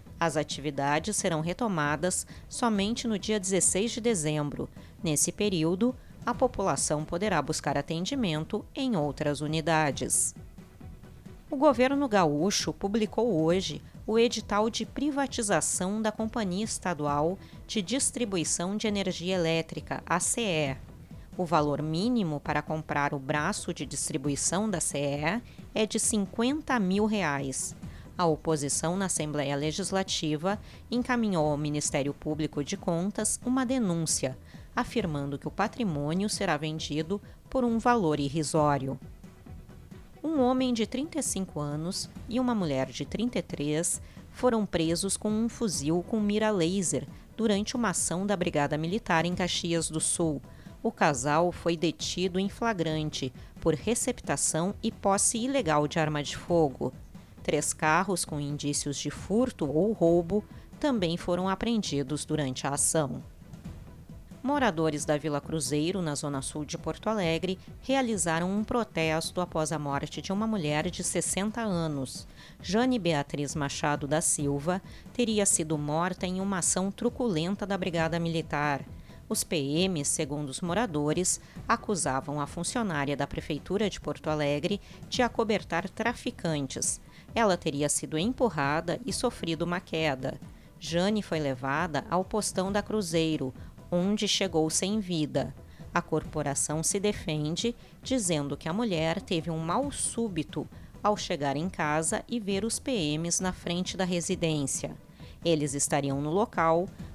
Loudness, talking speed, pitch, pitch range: -29 LUFS, 130 wpm, 170 Hz, 150-215 Hz